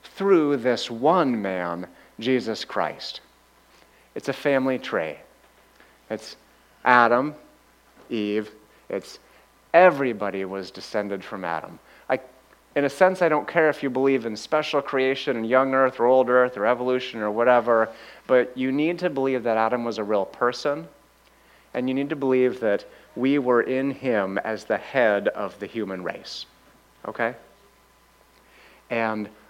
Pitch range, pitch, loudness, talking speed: 110-135 Hz, 125 Hz, -23 LUFS, 145 wpm